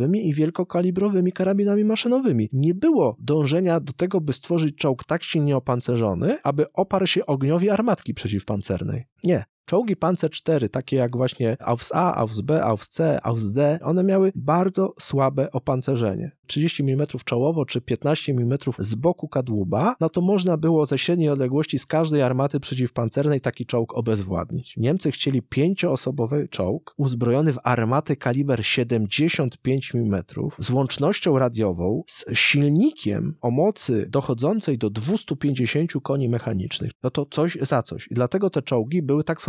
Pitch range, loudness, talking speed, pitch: 125-165 Hz, -22 LUFS, 140 wpm, 145 Hz